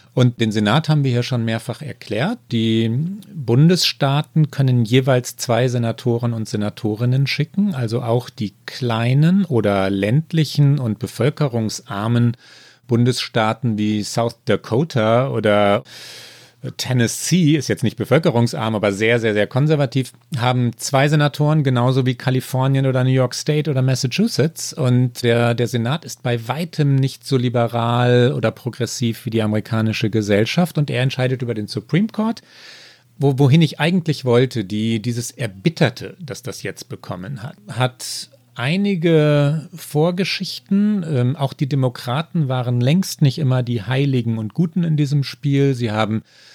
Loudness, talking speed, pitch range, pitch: -19 LUFS, 140 wpm, 115-150 Hz, 130 Hz